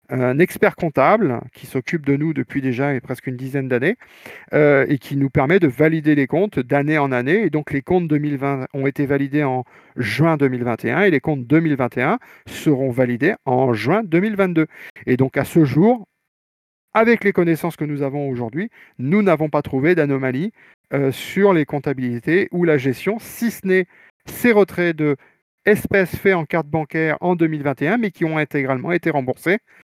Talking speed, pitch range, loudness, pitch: 175 wpm, 135-175 Hz, -19 LUFS, 150 Hz